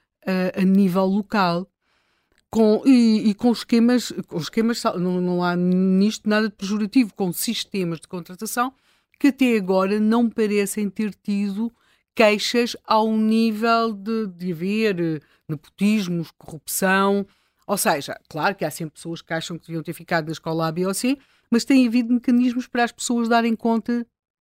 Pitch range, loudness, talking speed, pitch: 180-230 Hz, -21 LUFS, 160 wpm, 210 Hz